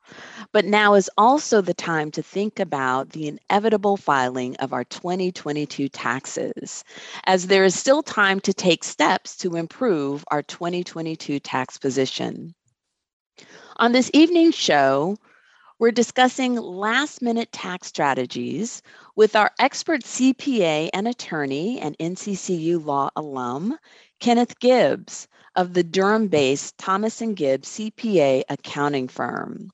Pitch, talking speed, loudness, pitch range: 185 Hz, 120 wpm, -21 LUFS, 145-225 Hz